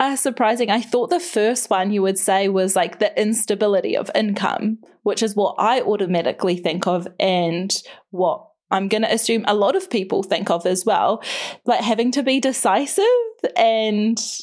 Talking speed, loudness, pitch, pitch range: 180 wpm, -20 LUFS, 215 Hz, 190-240 Hz